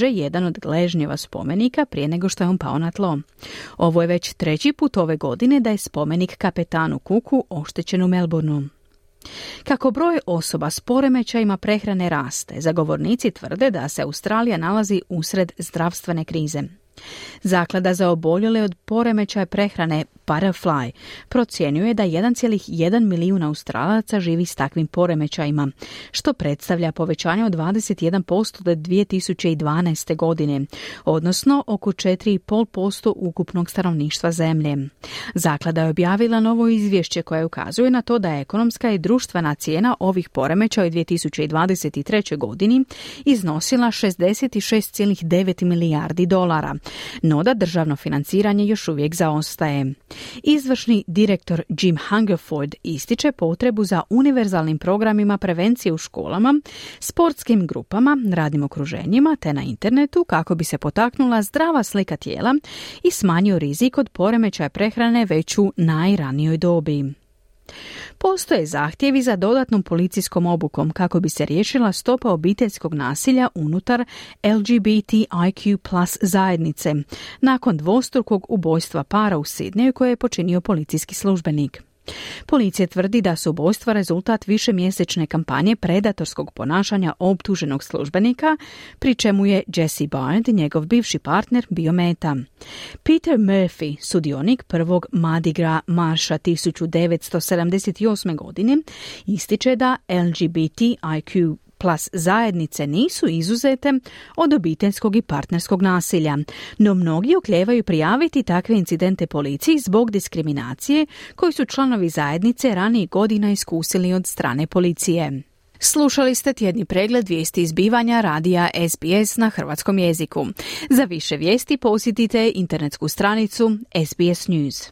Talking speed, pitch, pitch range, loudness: 120 wpm, 185 Hz, 160-220 Hz, -20 LUFS